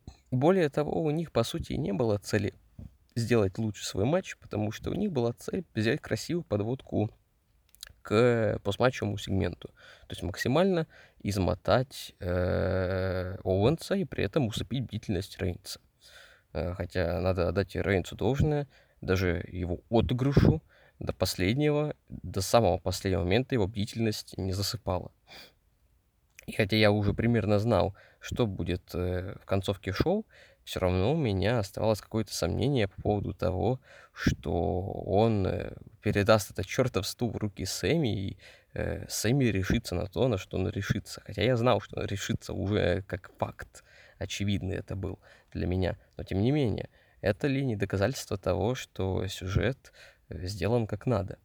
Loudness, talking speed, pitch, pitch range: -30 LUFS, 145 wpm, 105 Hz, 95-120 Hz